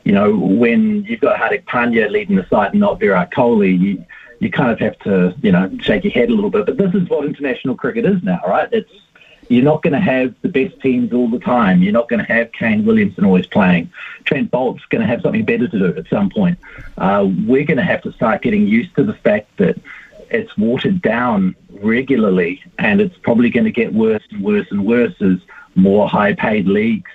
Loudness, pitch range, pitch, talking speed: -15 LUFS, 135-215 Hz, 200 Hz, 225 wpm